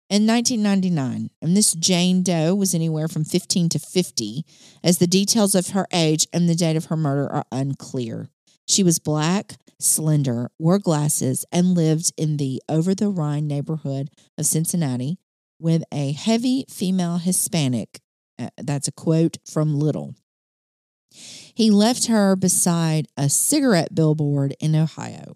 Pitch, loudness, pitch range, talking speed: 165 Hz, -20 LUFS, 150-185 Hz, 145 wpm